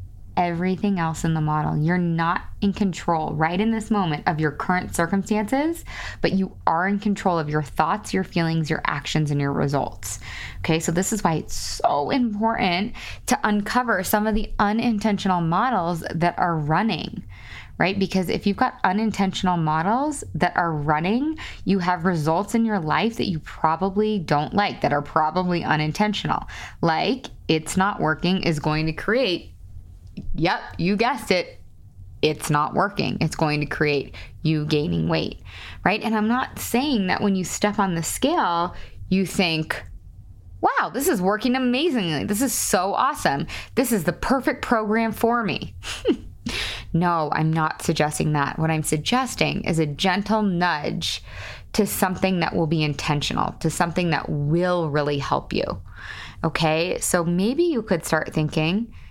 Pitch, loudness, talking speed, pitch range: 175 Hz, -23 LUFS, 160 wpm, 155-205 Hz